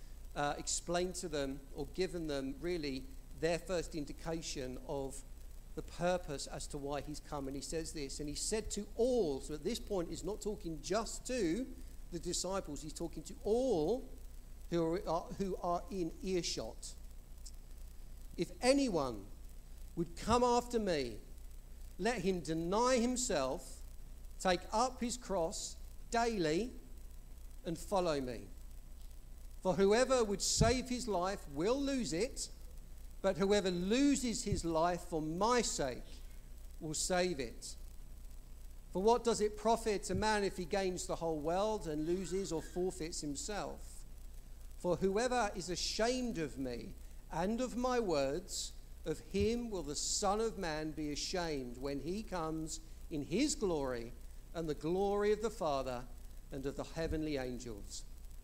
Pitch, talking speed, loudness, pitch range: 160 Hz, 145 wpm, -37 LUFS, 120-195 Hz